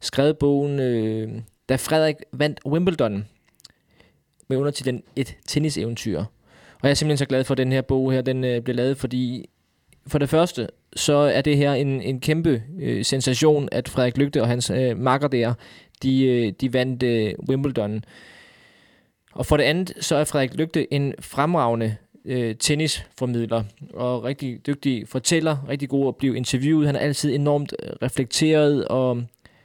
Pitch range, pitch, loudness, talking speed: 120-145 Hz, 130 Hz, -22 LUFS, 170 wpm